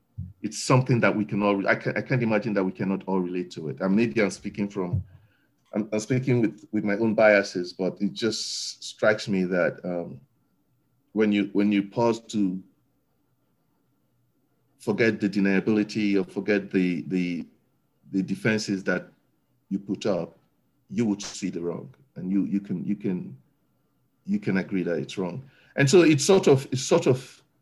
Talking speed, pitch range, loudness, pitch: 180 wpm, 95-115 Hz, -25 LUFS, 105 Hz